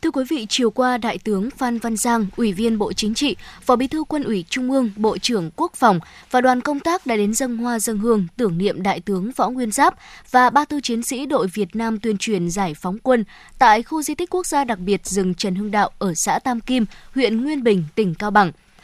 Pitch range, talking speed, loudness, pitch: 205-255 Hz, 250 wpm, -20 LUFS, 230 Hz